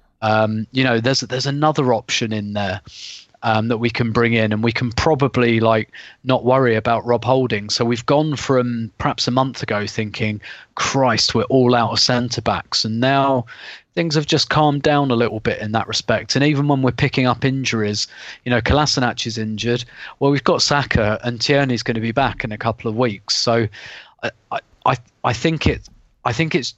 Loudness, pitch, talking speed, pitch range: -18 LUFS, 120 Hz, 200 wpm, 110-135 Hz